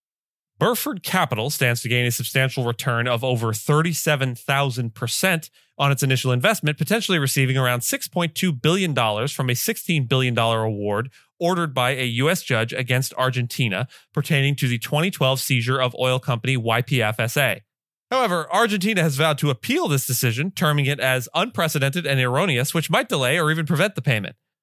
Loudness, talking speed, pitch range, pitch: -21 LUFS, 155 wpm, 125-165 Hz, 135 Hz